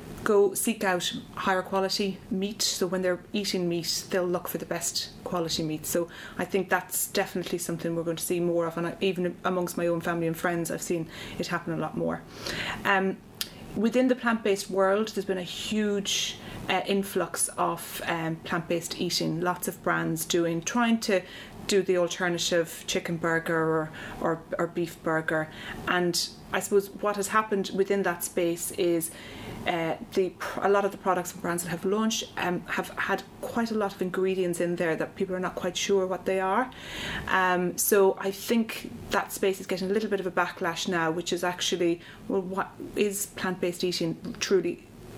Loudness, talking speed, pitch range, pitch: -28 LUFS, 190 wpm, 170-195 Hz, 185 Hz